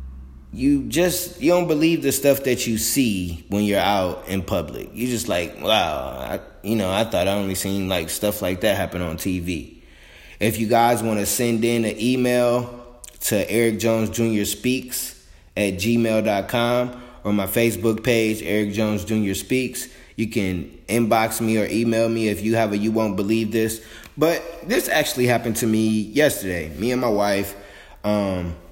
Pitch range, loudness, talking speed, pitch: 100-120 Hz, -21 LUFS, 180 wpm, 110 Hz